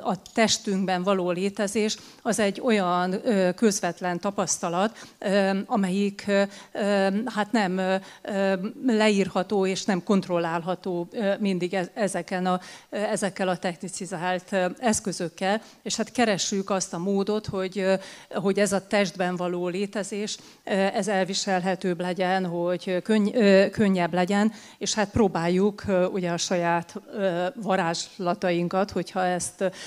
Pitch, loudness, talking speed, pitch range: 195 Hz, -25 LUFS, 105 wpm, 180-205 Hz